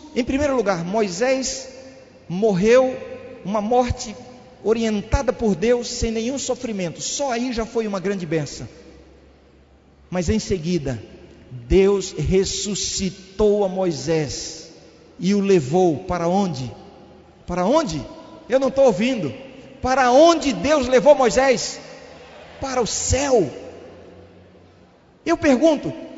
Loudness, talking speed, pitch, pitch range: -20 LUFS, 110 wpm, 220 Hz, 180-260 Hz